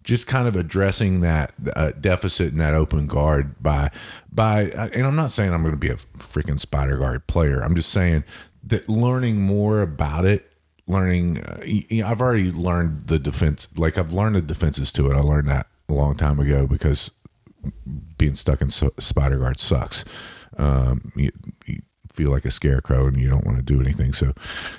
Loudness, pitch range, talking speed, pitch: -21 LUFS, 70-95 Hz, 195 wpm, 80 Hz